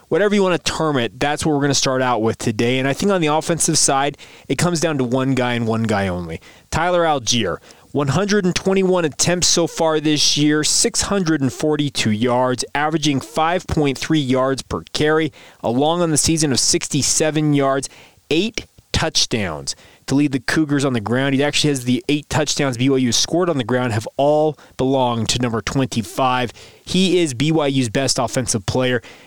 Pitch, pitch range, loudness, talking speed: 140 Hz, 125-155 Hz, -18 LUFS, 175 wpm